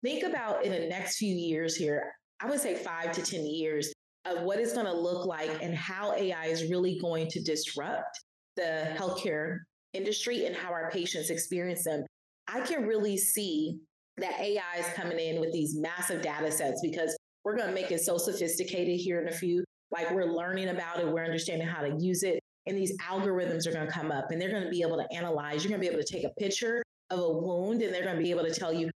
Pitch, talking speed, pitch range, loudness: 175 Hz, 235 wpm, 160-185 Hz, -32 LUFS